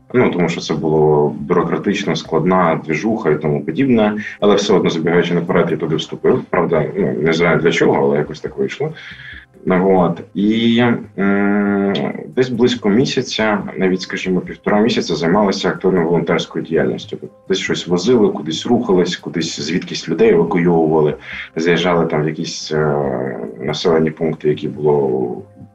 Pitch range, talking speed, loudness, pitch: 75-100 Hz, 150 wpm, -16 LUFS, 85 Hz